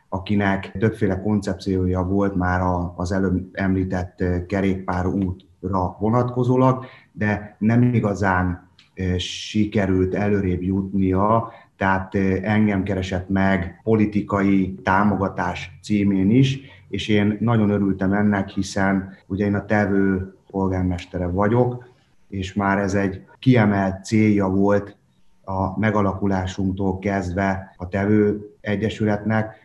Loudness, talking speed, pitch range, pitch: -21 LUFS, 100 wpm, 95-105 Hz, 100 Hz